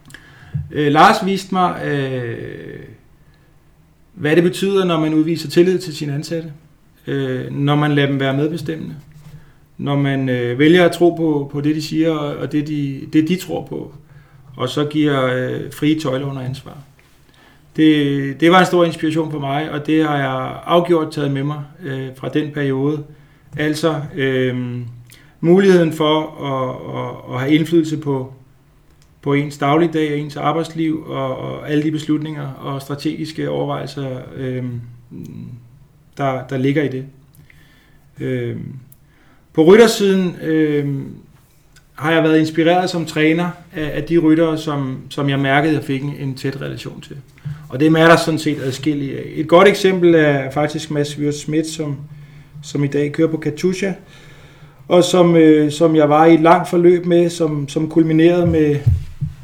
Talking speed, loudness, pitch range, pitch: 145 wpm, -17 LUFS, 140-160 Hz, 150 Hz